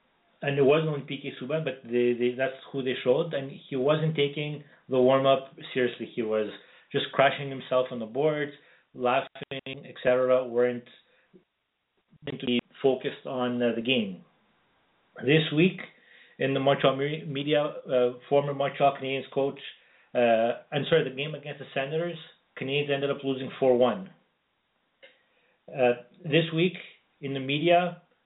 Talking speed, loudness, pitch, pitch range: 145 wpm, -27 LUFS, 135 Hz, 125-150 Hz